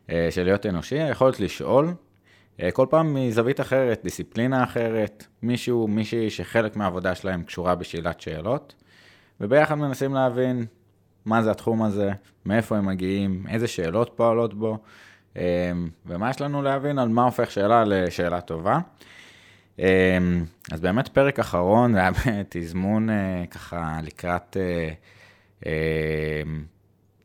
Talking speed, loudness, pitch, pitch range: 130 wpm, -24 LUFS, 100 Hz, 90-115 Hz